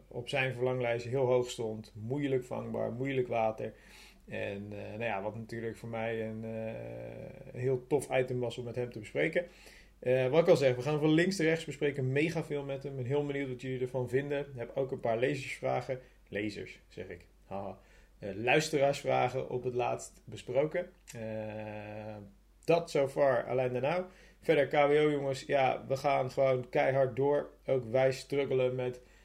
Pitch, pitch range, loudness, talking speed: 130 Hz, 115-140 Hz, -32 LUFS, 185 wpm